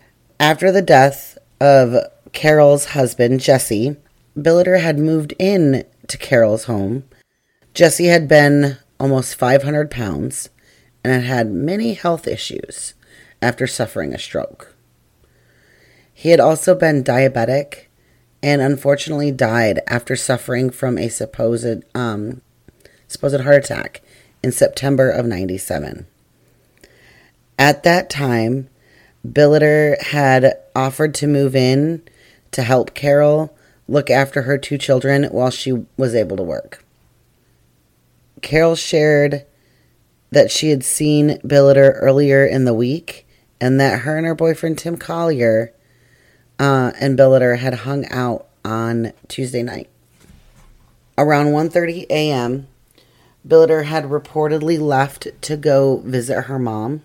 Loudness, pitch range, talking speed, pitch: -16 LUFS, 125-150 Hz, 120 wpm, 135 Hz